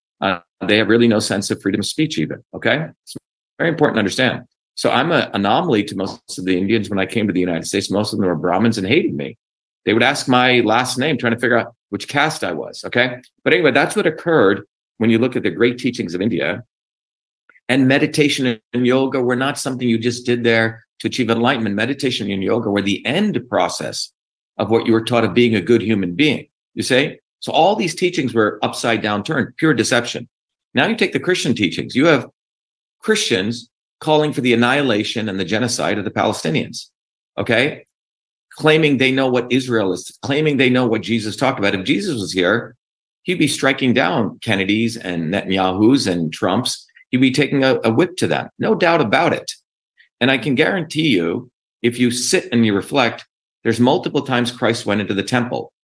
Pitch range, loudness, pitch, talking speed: 105-130 Hz, -17 LUFS, 115 Hz, 205 wpm